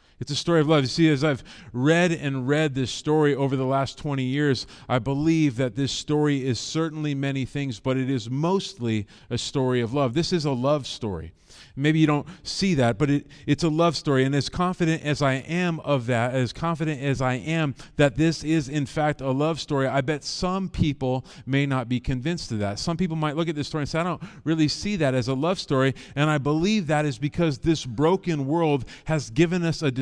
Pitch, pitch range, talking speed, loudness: 145 Hz, 130-160 Hz, 230 wpm, -24 LUFS